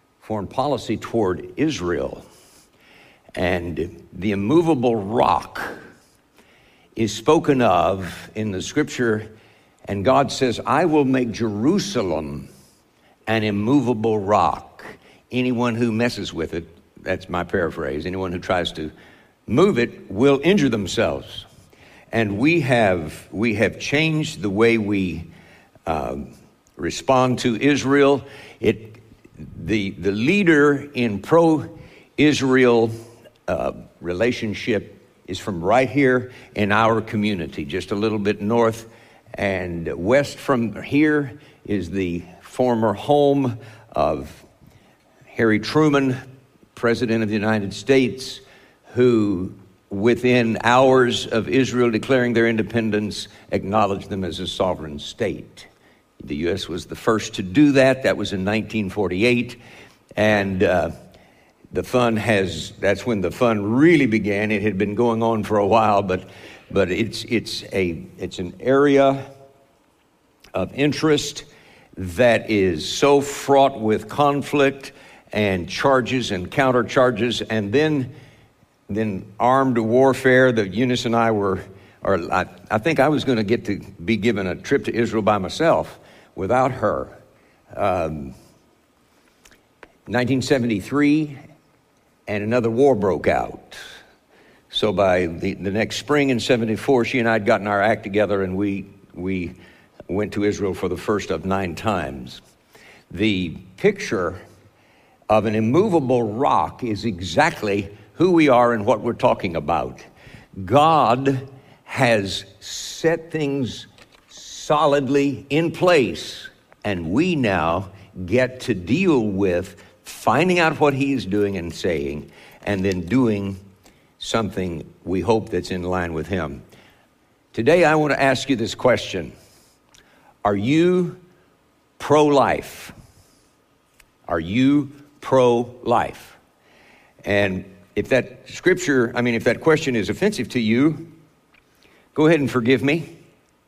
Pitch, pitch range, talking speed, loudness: 115 Hz, 100-135 Hz, 125 wpm, -20 LUFS